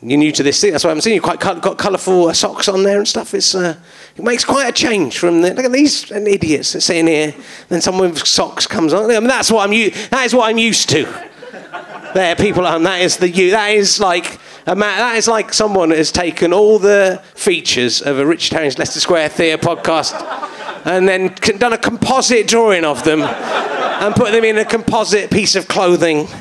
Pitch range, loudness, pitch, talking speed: 170-220 Hz, -13 LUFS, 190 Hz, 230 wpm